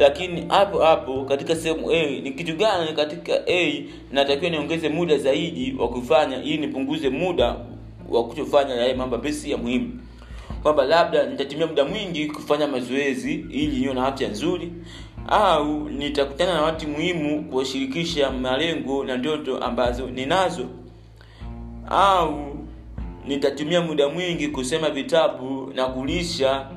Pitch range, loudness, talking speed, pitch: 130-160 Hz, -23 LUFS, 130 wpm, 145 Hz